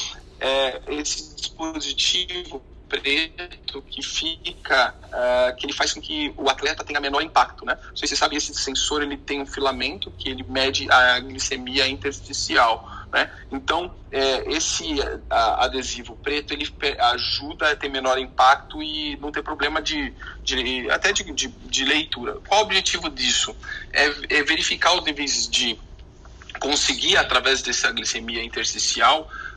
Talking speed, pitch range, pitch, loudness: 145 wpm, 125-155 Hz, 135 Hz, -22 LUFS